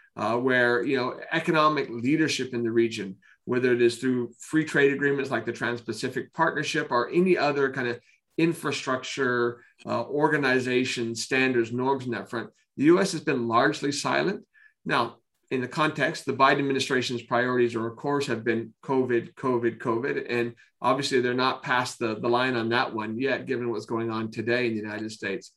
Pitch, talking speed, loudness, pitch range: 125 Hz, 180 wpm, -26 LUFS, 120-135 Hz